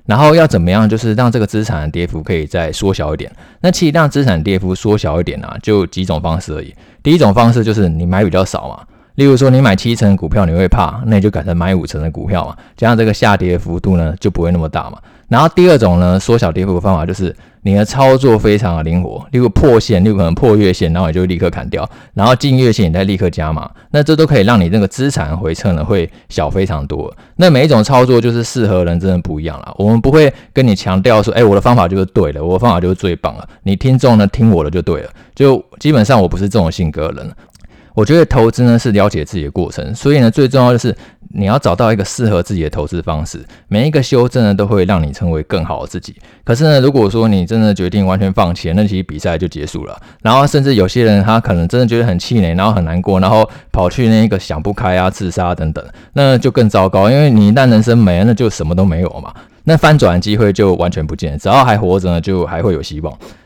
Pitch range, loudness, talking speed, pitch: 90-115 Hz, -12 LUFS, 375 characters per minute, 100 Hz